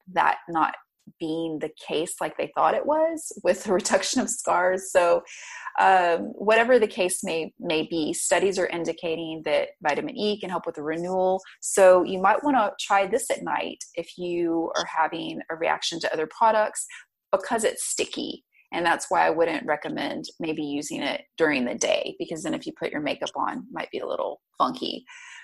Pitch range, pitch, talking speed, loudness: 170-250 Hz, 190 Hz, 200 wpm, -25 LUFS